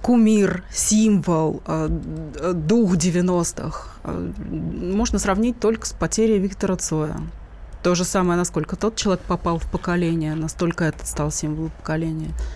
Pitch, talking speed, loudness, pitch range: 175 Hz, 120 wpm, -22 LUFS, 160-195 Hz